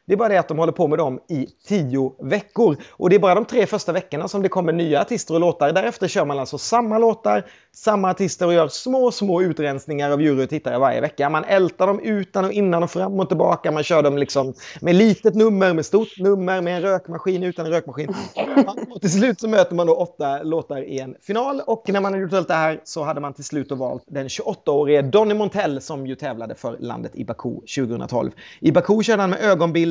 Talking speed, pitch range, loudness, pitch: 235 wpm, 150-200 Hz, -20 LUFS, 180 Hz